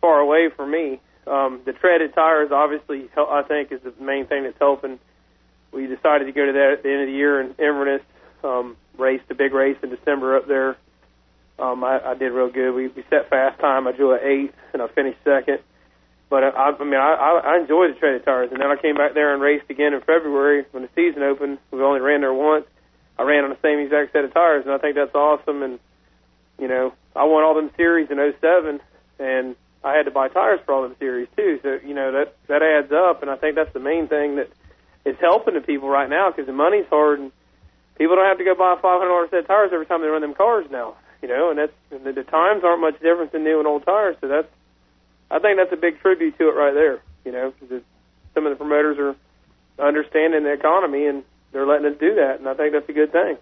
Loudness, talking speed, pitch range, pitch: -19 LUFS, 250 wpm, 135-155 Hz, 145 Hz